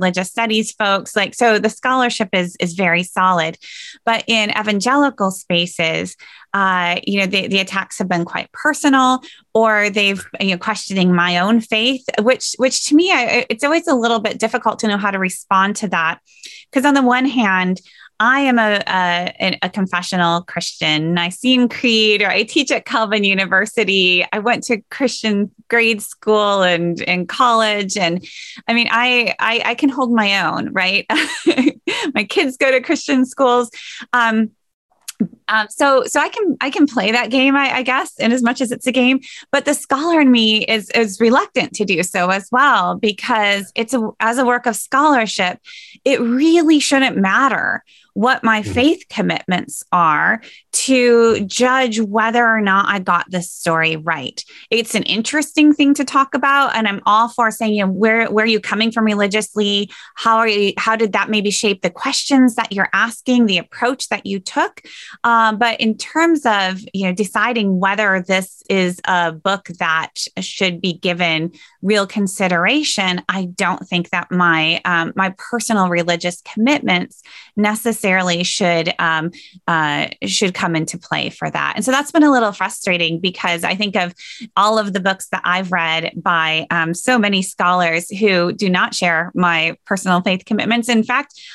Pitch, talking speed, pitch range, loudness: 215 Hz, 175 wpm, 185-245 Hz, -16 LUFS